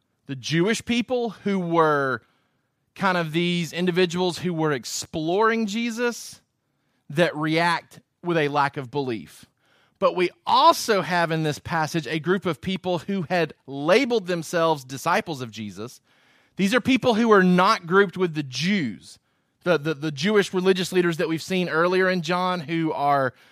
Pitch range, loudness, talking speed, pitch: 155-190 Hz, -23 LUFS, 160 wpm, 175 Hz